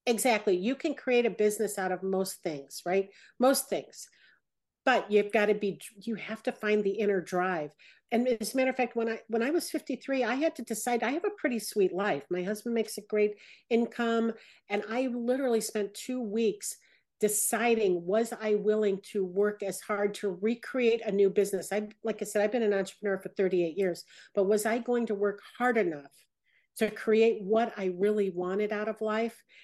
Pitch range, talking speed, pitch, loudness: 200-235 Hz, 200 wpm, 215 Hz, -30 LUFS